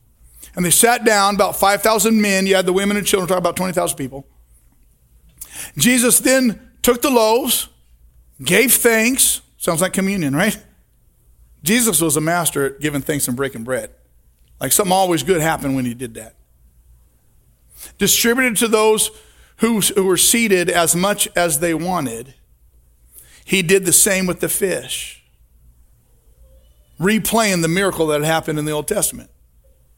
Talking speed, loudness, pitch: 150 wpm, -16 LUFS, 175 Hz